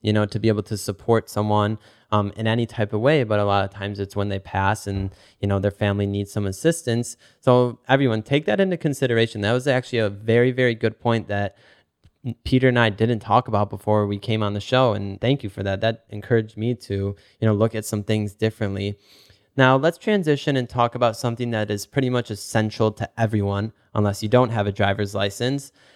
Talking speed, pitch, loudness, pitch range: 220 wpm, 110 Hz, -22 LUFS, 100-120 Hz